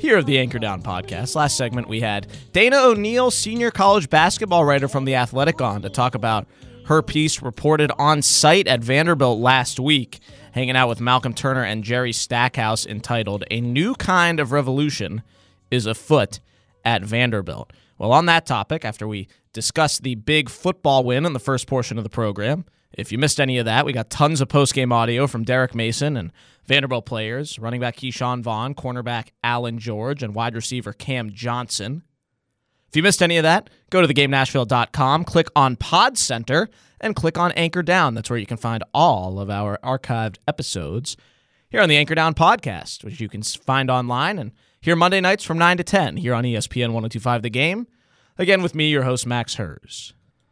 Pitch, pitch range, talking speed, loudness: 130 Hz, 115-150 Hz, 190 wpm, -19 LUFS